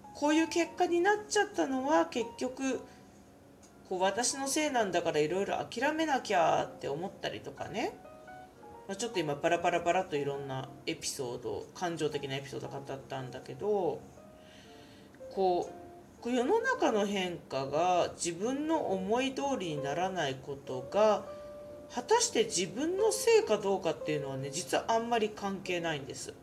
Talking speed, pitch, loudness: 320 characters per minute, 200 Hz, -32 LUFS